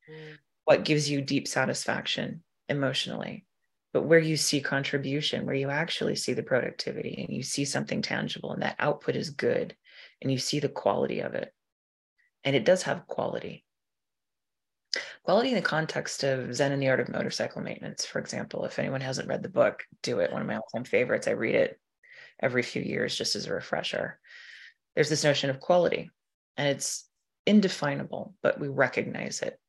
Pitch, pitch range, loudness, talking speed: 145 Hz, 135-165 Hz, -29 LUFS, 180 wpm